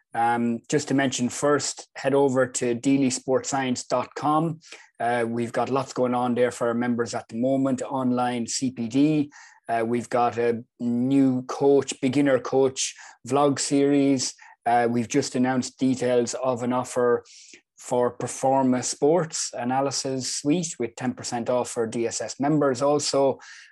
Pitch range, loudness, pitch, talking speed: 120-135 Hz, -24 LUFS, 125 Hz, 135 wpm